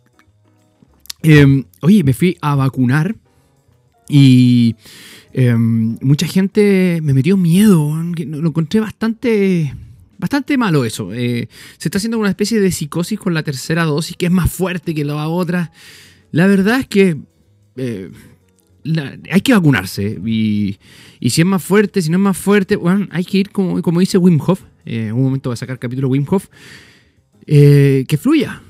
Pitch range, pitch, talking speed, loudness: 125-190 Hz, 155 Hz, 170 wpm, -15 LUFS